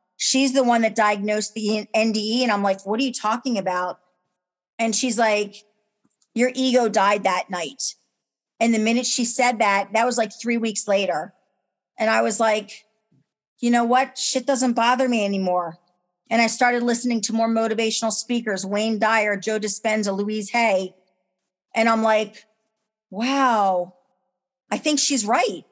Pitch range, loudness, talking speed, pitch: 200-240 Hz, -21 LUFS, 160 wpm, 220 Hz